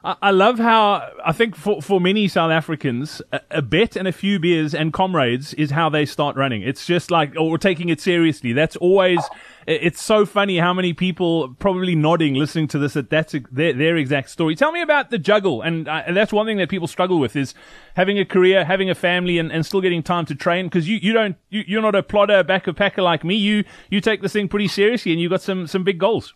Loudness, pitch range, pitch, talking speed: -19 LUFS, 160-200 Hz, 180 Hz, 245 wpm